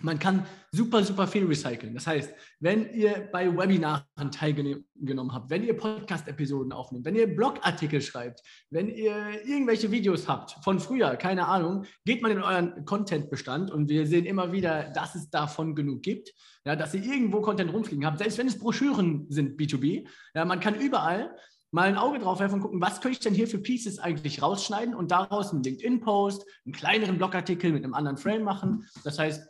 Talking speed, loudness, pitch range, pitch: 190 wpm, -28 LUFS, 150-210 Hz, 185 Hz